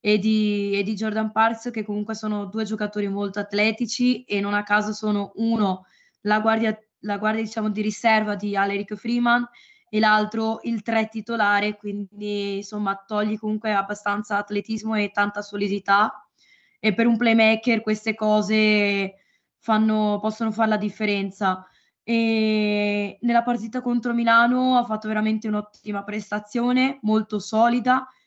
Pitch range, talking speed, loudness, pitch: 205-225 Hz, 140 wpm, -23 LUFS, 215 Hz